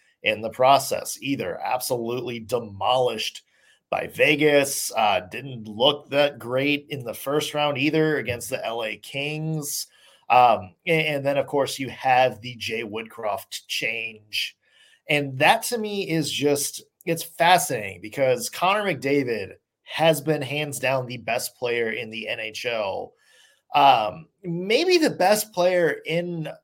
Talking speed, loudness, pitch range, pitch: 135 wpm, -23 LUFS, 125-160 Hz, 145 Hz